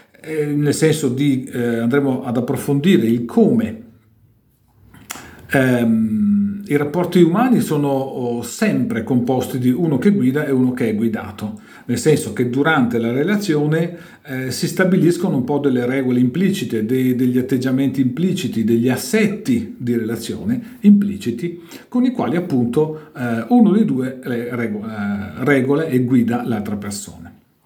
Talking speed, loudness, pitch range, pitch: 135 wpm, -18 LUFS, 120-175 Hz, 135 Hz